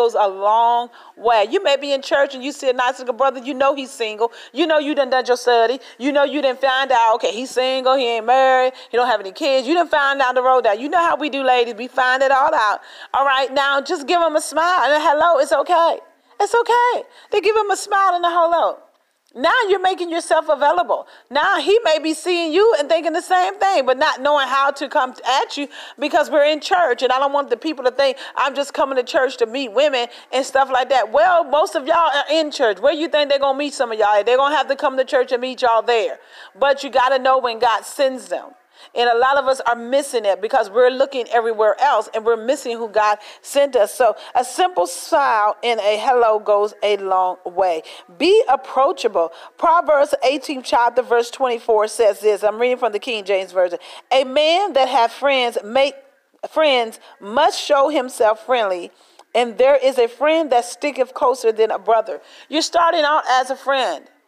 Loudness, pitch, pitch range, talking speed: -17 LUFS, 270 Hz, 240-305 Hz, 230 wpm